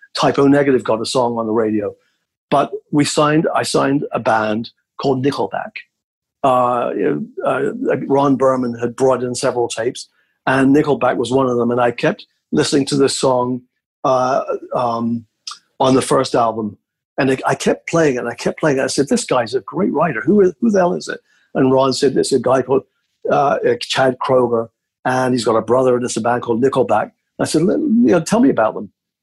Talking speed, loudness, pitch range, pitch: 210 wpm, -16 LUFS, 120-140 Hz, 130 Hz